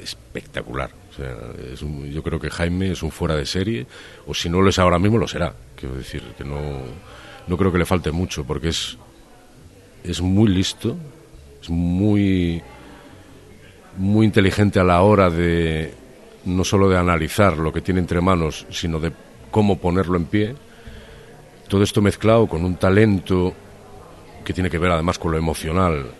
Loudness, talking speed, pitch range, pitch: -20 LUFS, 170 wpm, 80-95 Hz, 90 Hz